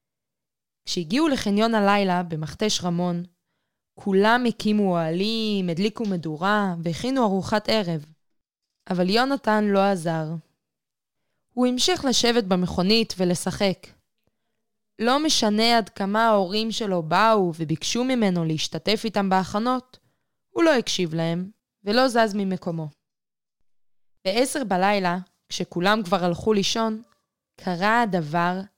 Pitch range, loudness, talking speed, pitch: 180-225 Hz, -23 LUFS, 100 wpm, 200 Hz